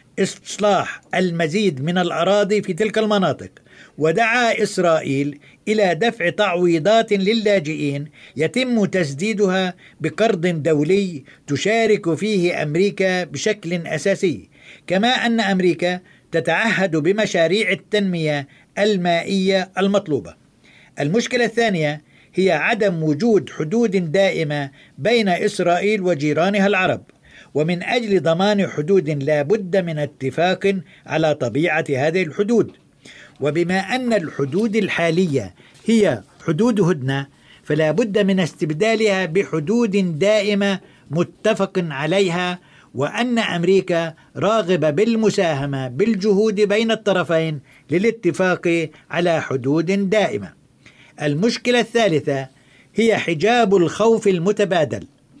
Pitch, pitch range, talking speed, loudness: 185 Hz, 155-210 Hz, 90 wpm, -19 LUFS